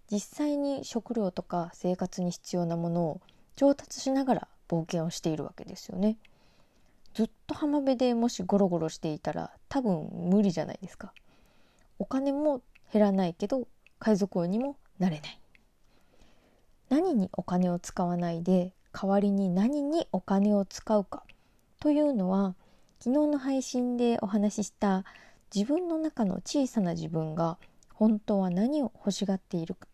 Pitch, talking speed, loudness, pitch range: 200 Hz, 285 characters per minute, -30 LUFS, 180-250 Hz